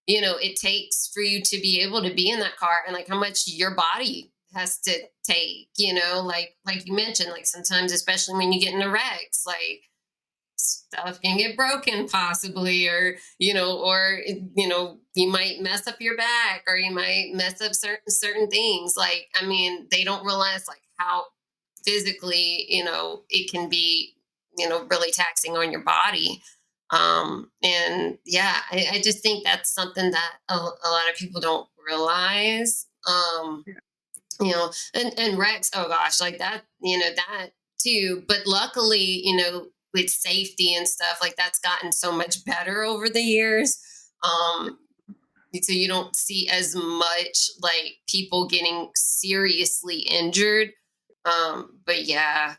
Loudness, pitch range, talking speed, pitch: -22 LUFS, 175-200 Hz, 170 wpm, 185 Hz